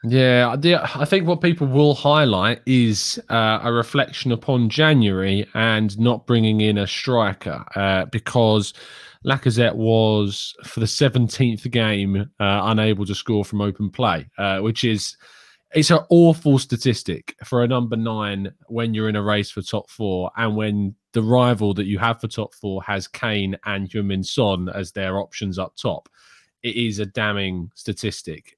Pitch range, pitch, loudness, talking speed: 100-125 Hz, 110 Hz, -20 LUFS, 165 wpm